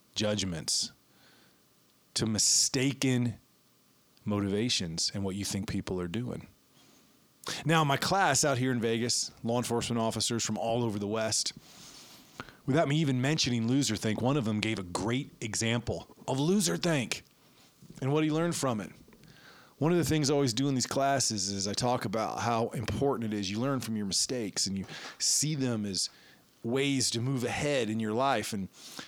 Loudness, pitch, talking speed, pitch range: -30 LUFS, 120 Hz, 175 wpm, 110-140 Hz